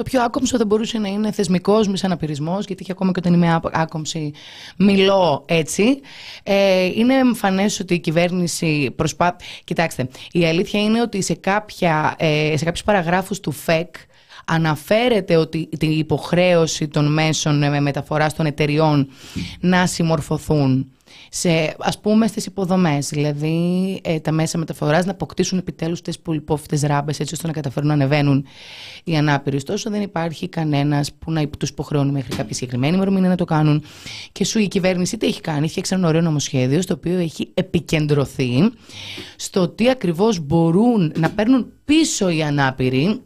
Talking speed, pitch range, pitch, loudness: 160 wpm, 150-190 Hz, 165 Hz, -19 LUFS